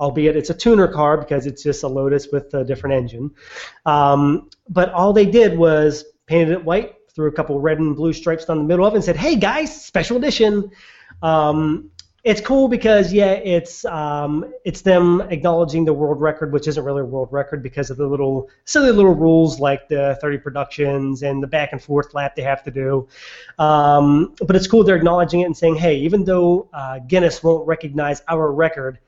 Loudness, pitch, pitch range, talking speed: -17 LUFS, 155 Hz, 145-175 Hz, 205 wpm